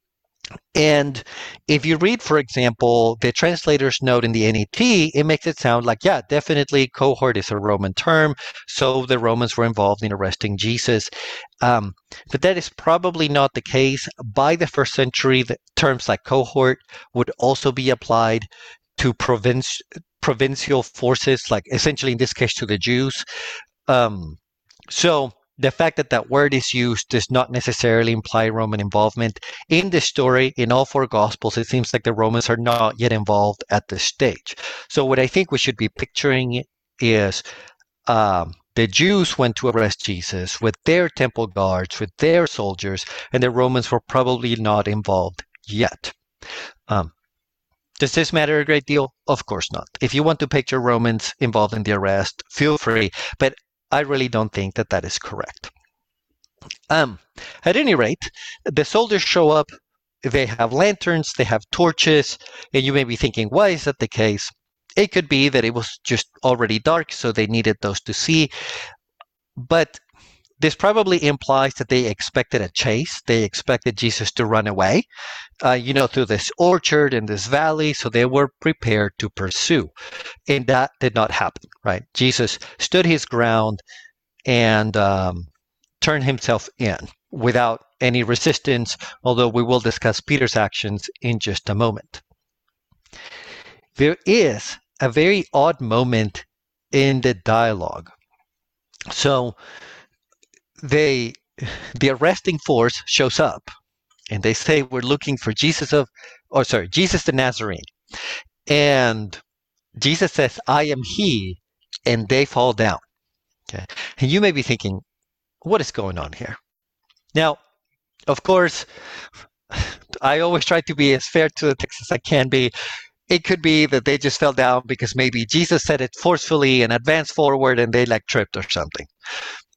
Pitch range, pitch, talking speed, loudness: 115-150 Hz, 125 Hz, 160 wpm, -19 LUFS